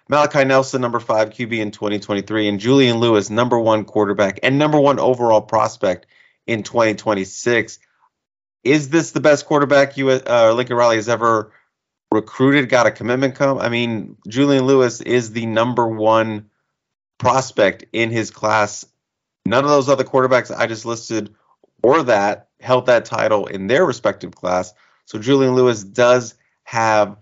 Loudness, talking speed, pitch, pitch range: -17 LUFS, 155 wpm, 120 Hz, 110-135 Hz